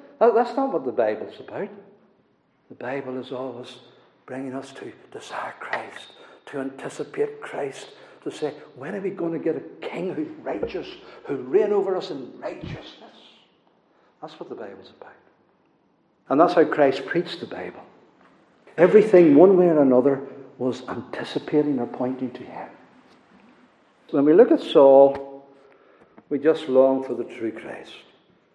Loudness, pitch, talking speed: -21 LUFS, 145 Hz, 150 wpm